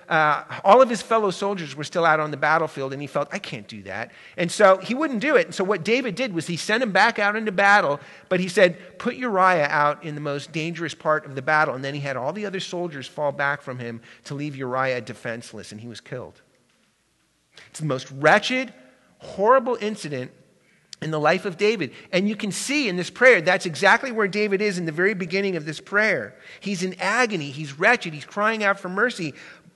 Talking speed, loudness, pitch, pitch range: 225 wpm, -22 LUFS, 175 Hz, 145-205 Hz